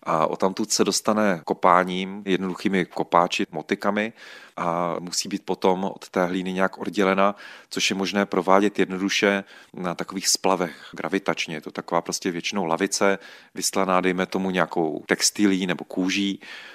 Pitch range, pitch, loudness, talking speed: 90-100 Hz, 95 Hz, -23 LUFS, 145 wpm